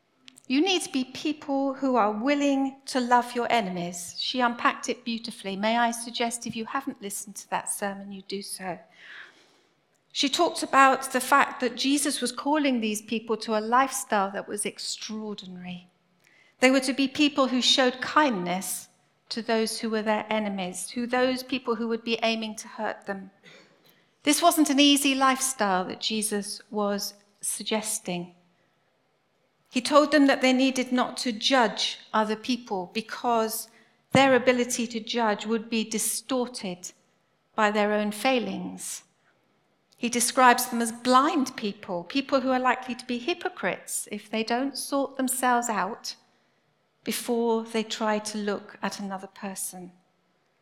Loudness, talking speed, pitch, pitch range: -26 LUFS, 155 wpm, 235 Hz, 210-260 Hz